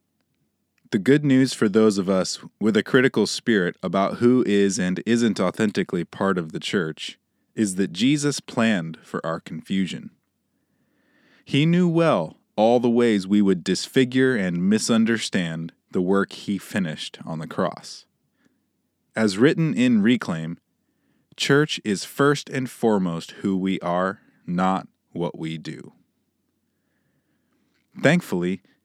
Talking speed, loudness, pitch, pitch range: 130 wpm, -22 LUFS, 110 Hz, 95-140 Hz